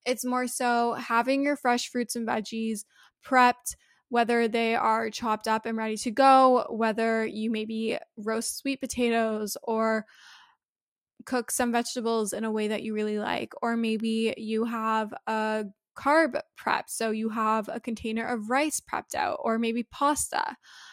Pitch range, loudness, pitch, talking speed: 220-245 Hz, -27 LUFS, 230 Hz, 160 wpm